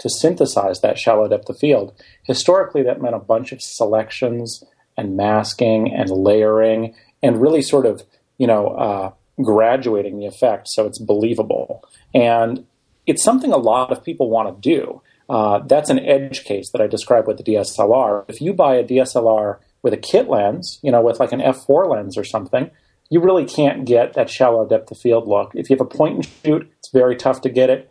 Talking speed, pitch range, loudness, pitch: 195 wpm, 105-130 Hz, -17 LUFS, 115 Hz